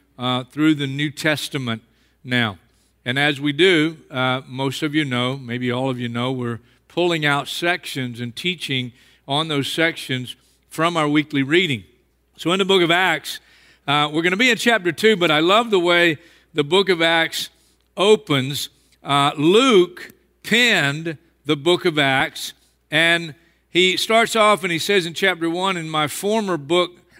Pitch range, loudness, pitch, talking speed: 135-180 Hz, -19 LUFS, 155 Hz, 170 wpm